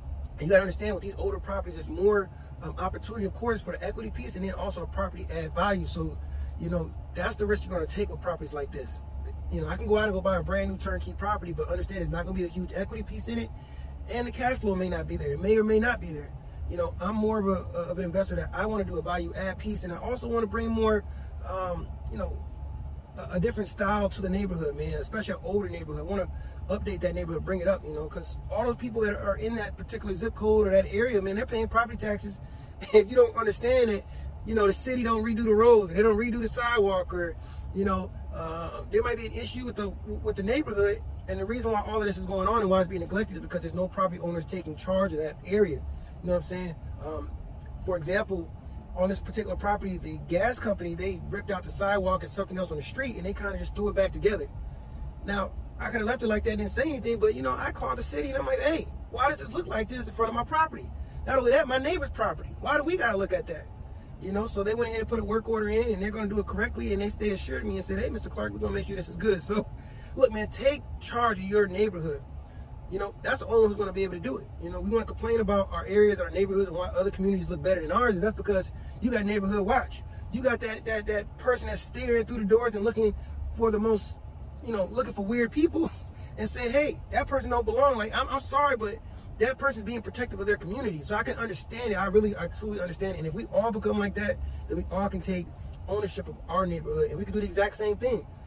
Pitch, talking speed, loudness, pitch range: 205 Hz, 270 wpm, -29 LUFS, 180-230 Hz